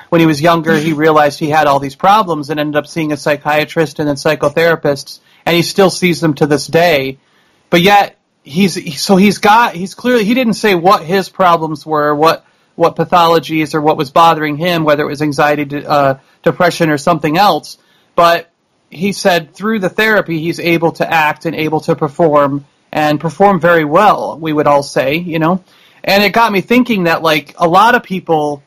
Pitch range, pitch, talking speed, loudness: 150-180 Hz, 165 Hz, 200 wpm, -12 LUFS